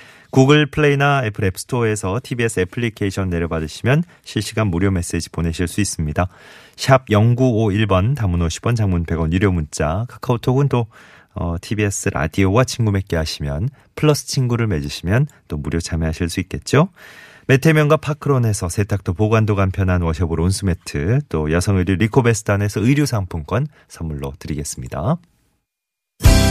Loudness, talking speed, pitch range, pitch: -19 LUFS, 340 characters per minute, 85-120 Hz, 100 Hz